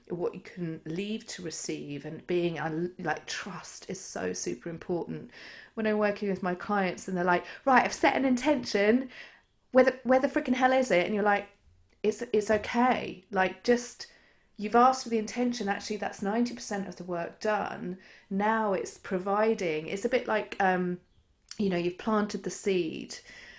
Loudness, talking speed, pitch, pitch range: -29 LUFS, 180 wpm, 205 Hz, 180-230 Hz